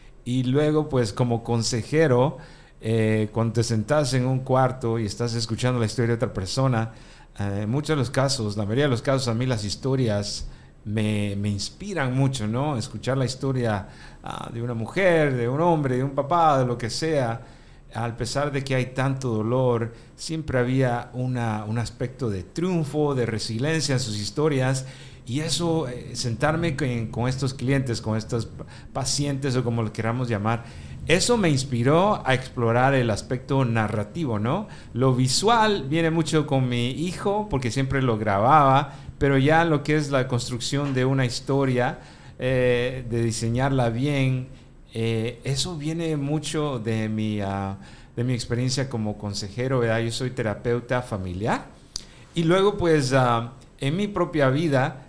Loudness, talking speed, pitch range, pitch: -24 LUFS, 160 wpm, 115-140 Hz, 130 Hz